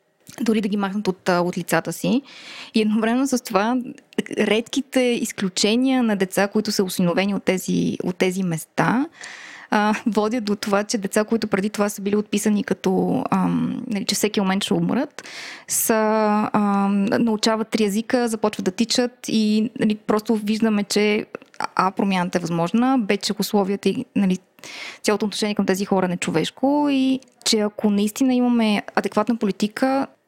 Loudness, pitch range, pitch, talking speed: -21 LUFS, 200-235 Hz, 215 Hz, 160 wpm